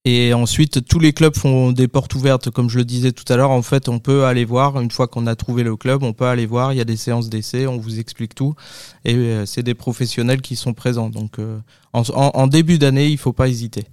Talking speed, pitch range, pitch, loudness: 255 wpm, 120-135 Hz, 125 Hz, -17 LUFS